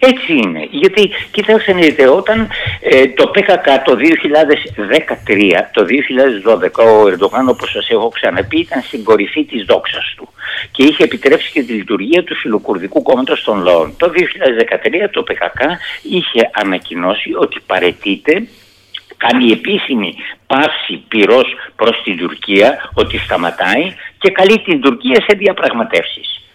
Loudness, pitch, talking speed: -12 LUFS, 210 Hz, 130 wpm